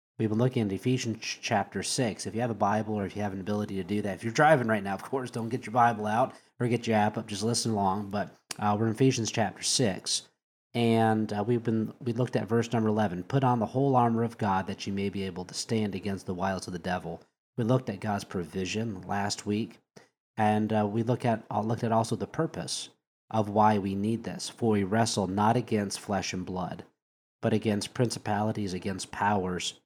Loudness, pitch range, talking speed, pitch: -29 LUFS, 100-115 Hz, 230 wpm, 110 Hz